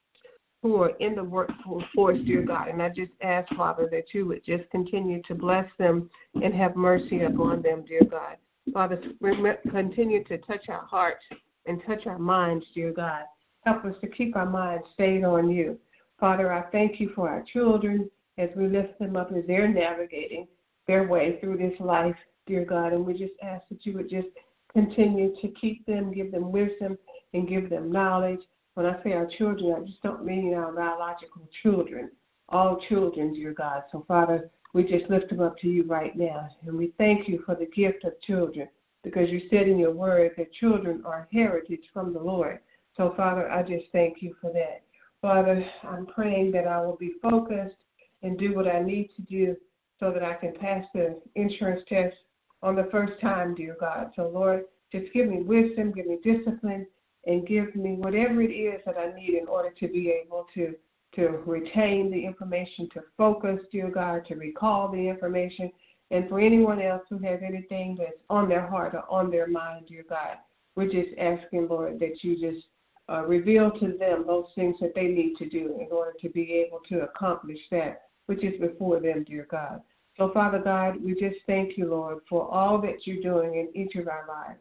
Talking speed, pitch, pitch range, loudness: 195 wpm, 180 Hz, 170-195 Hz, -27 LUFS